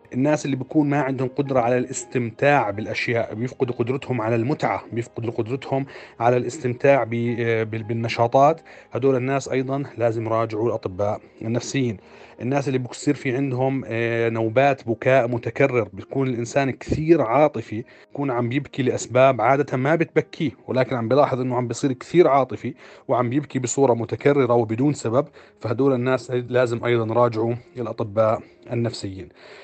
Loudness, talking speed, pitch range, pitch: -22 LUFS, 130 wpm, 115-135 Hz, 125 Hz